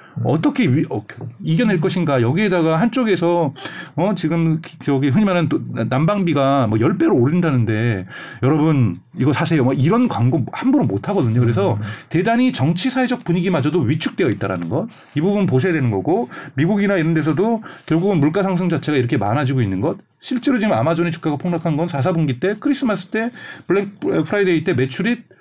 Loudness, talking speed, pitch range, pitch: -18 LUFS, 385 characters per minute, 135-195 Hz, 165 Hz